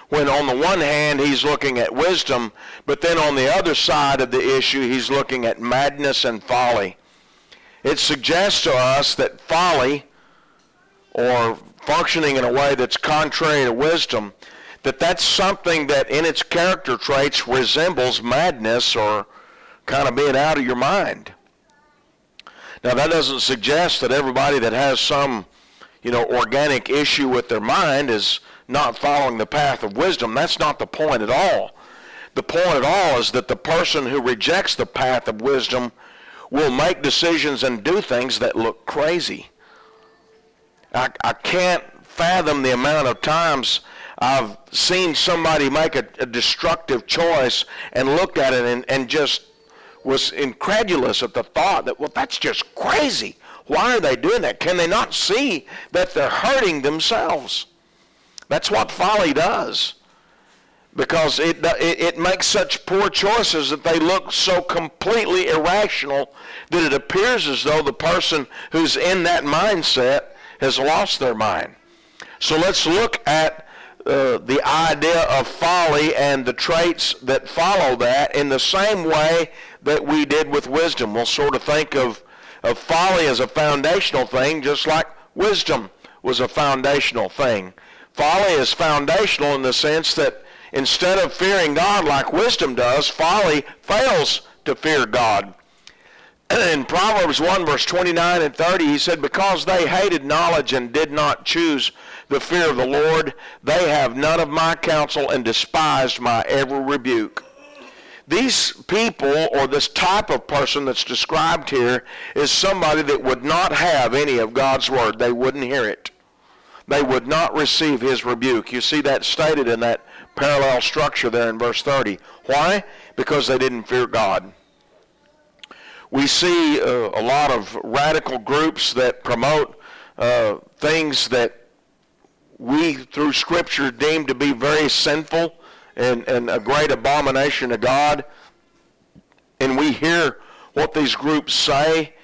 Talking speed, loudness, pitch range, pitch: 155 wpm, -18 LUFS, 135-170 Hz, 150 Hz